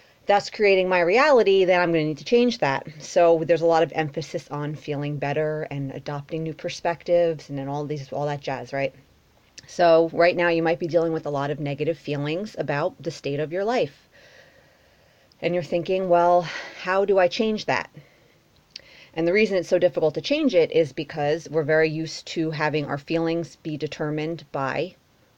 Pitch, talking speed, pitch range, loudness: 165 Hz, 195 wpm, 150-175 Hz, -23 LUFS